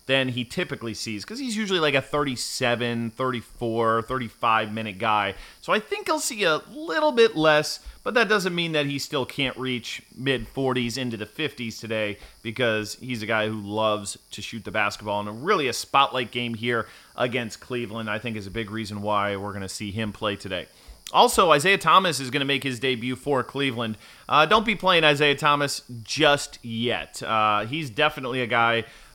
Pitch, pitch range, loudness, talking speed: 125 Hz, 110-145 Hz, -24 LUFS, 195 wpm